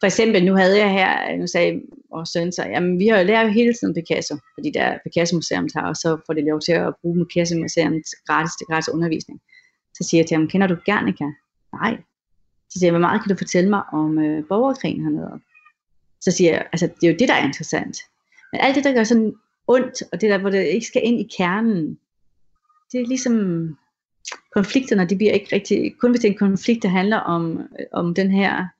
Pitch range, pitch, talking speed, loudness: 165-220 Hz, 185 Hz, 230 wpm, -19 LUFS